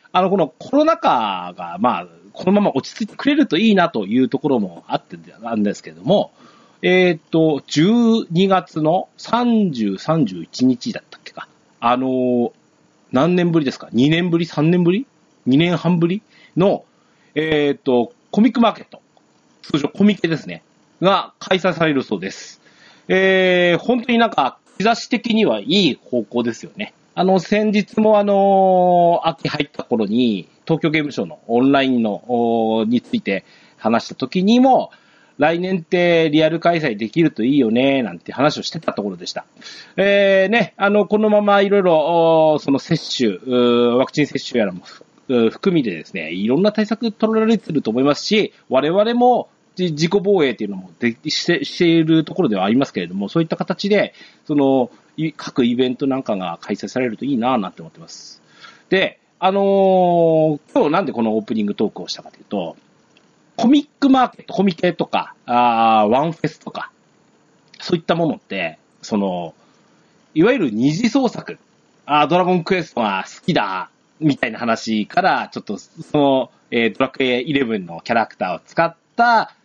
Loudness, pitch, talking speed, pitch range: -18 LUFS, 170 Hz, 325 characters per minute, 135-200 Hz